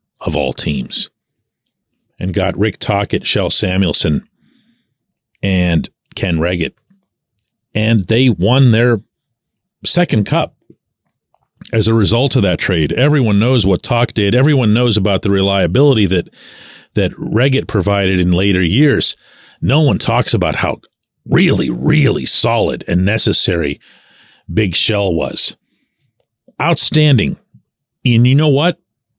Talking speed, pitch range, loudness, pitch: 120 wpm, 95-125 Hz, -14 LUFS, 110 Hz